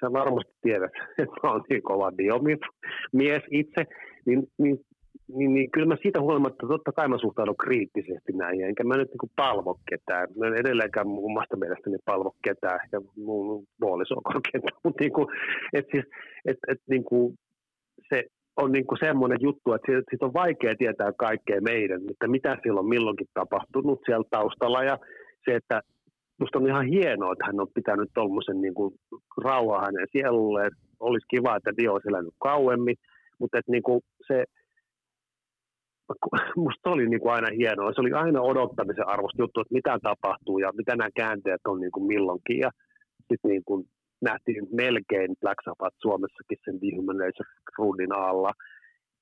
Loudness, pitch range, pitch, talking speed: -27 LUFS, 105-140 Hz, 125 Hz, 155 wpm